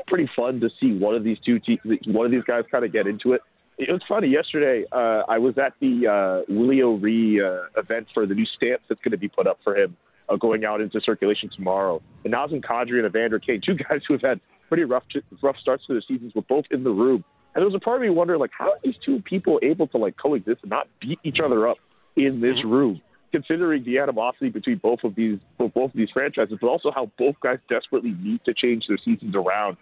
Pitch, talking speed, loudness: 125 Hz, 245 wpm, -23 LUFS